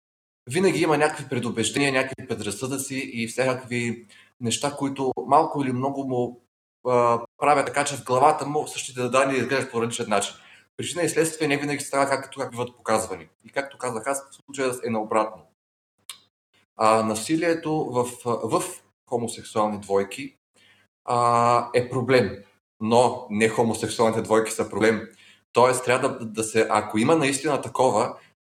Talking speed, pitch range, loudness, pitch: 145 wpm, 110-135 Hz, -24 LUFS, 125 Hz